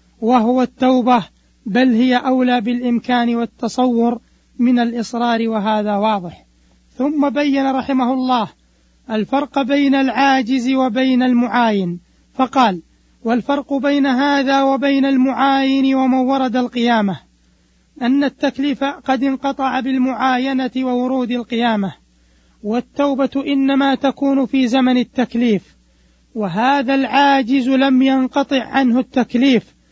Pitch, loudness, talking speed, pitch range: 255 Hz, -16 LUFS, 95 wpm, 235-270 Hz